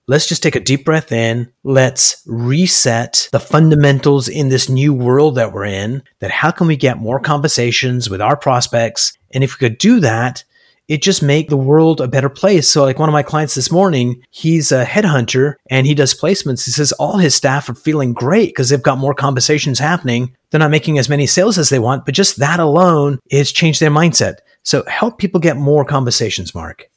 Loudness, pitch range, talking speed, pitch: -13 LUFS, 130-155 Hz, 210 wpm, 140 Hz